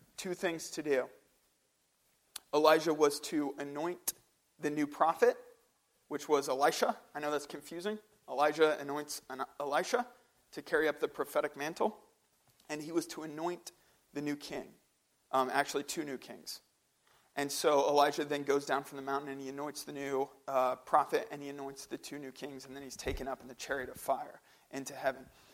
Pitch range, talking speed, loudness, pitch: 140-165 Hz, 175 wpm, -35 LUFS, 145 Hz